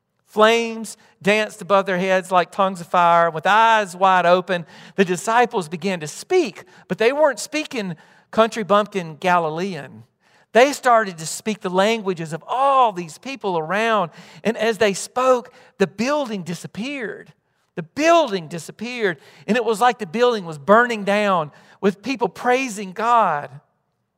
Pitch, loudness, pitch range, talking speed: 205 Hz, -19 LUFS, 180-230 Hz, 145 wpm